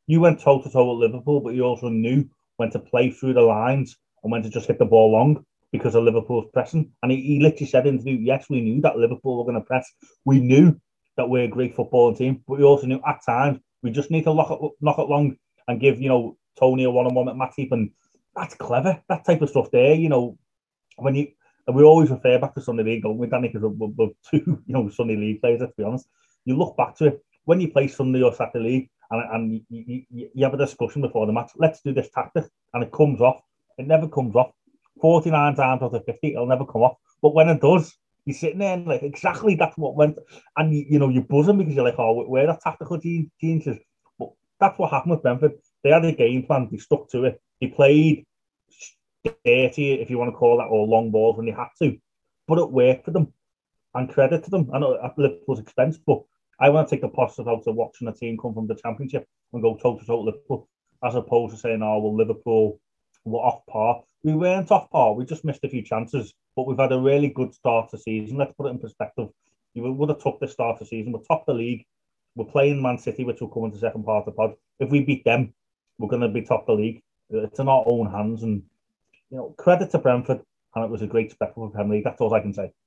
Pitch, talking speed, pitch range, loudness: 130 Hz, 250 wpm, 115-150 Hz, -21 LUFS